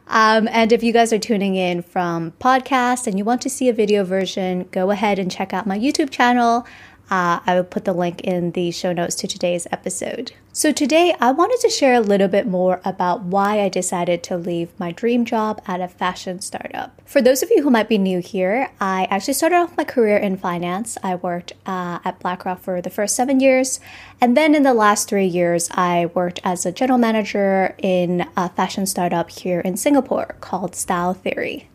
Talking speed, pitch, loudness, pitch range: 210 wpm, 195 Hz, -19 LUFS, 180-240 Hz